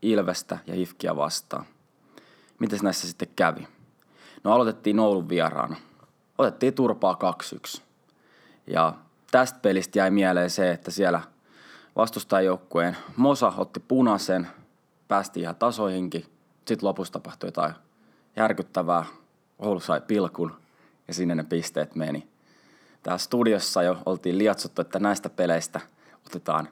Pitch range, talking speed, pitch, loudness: 85-105 Hz, 115 wpm, 95 Hz, -26 LUFS